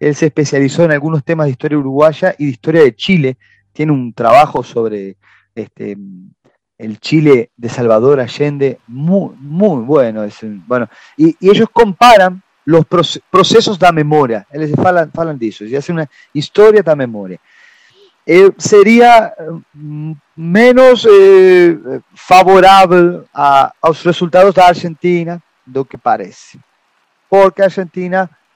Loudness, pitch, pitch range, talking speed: -10 LUFS, 160 Hz, 140-190 Hz, 130 wpm